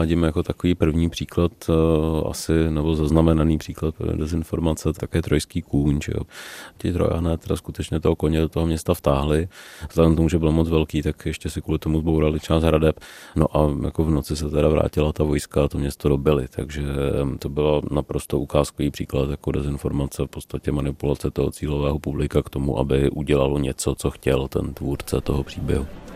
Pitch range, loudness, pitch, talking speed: 70-80 Hz, -22 LUFS, 75 Hz, 175 wpm